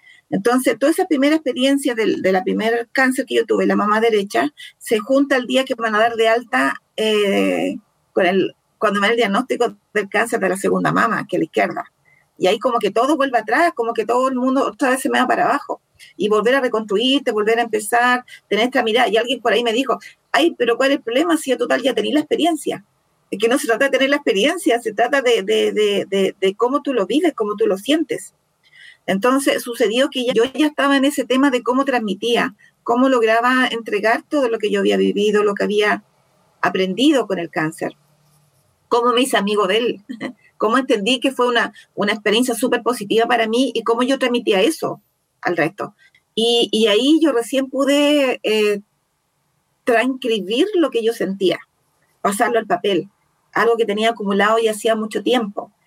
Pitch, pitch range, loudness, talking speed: 240 Hz, 215-270 Hz, -18 LUFS, 205 wpm